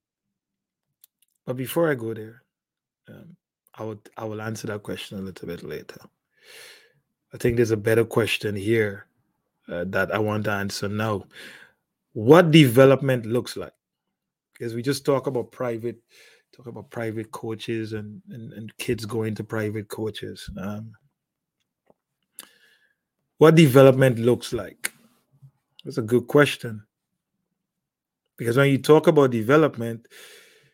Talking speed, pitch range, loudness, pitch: 135 wpm, 110-135 Hz, -22 LUFS, 115 Hz